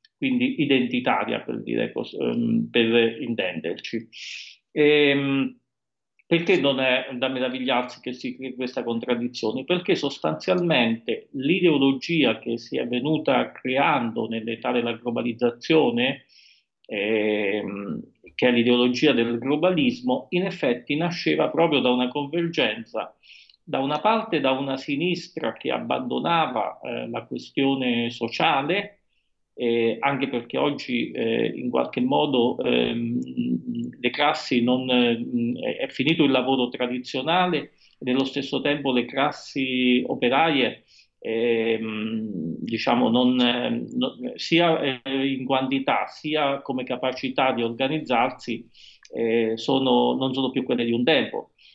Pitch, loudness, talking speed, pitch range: 130 Hz, -23 LUFS, 115 wpm, 120-150 Hz